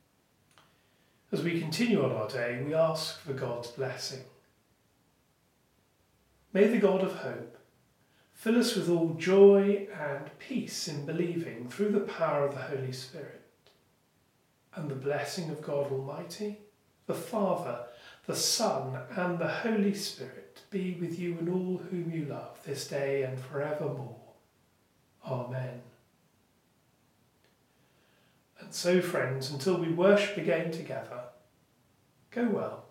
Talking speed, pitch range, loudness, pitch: 125 wpm, 135-185 Hz, -31 LUFS, 160 Hz